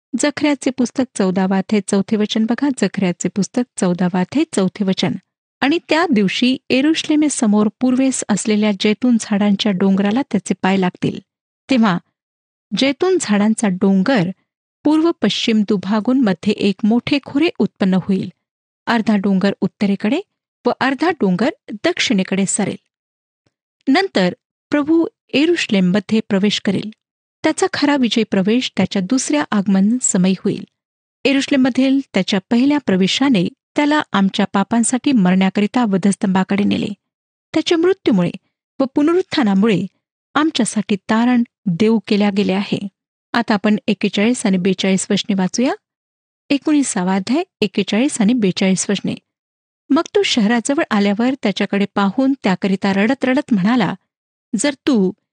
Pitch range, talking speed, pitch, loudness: 200-270 Hz, 110 wpm, 215 Hz, -17 LUFS